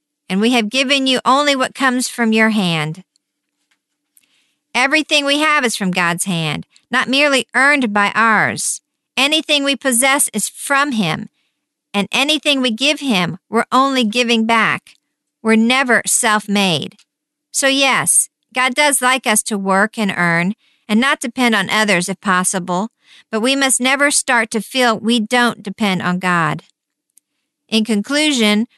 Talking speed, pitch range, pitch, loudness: 150 wpm, 210-275 Hz, 245 Hz, -15 LUFS